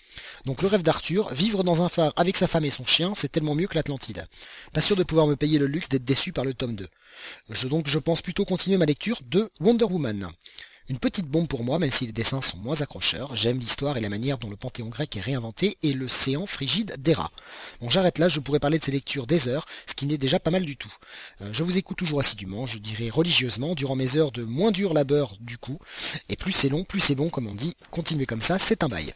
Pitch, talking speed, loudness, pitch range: 145 Hz, 260 wpm, -22 LUFS, 125-170 Hz